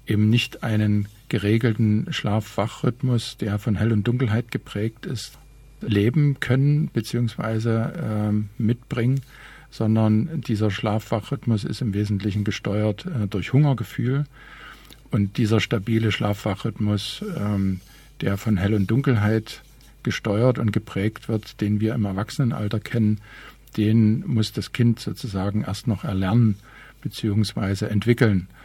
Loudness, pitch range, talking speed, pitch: -23 LUFS, 105-120 Hz, 115 wpm, 110 Hz